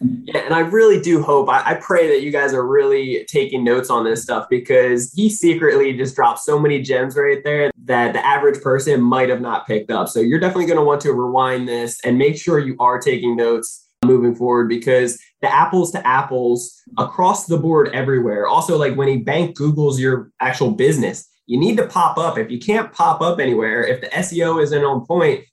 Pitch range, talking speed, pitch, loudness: 125-185 Hz, 215 wpm, 145 Hz, -17 LUFS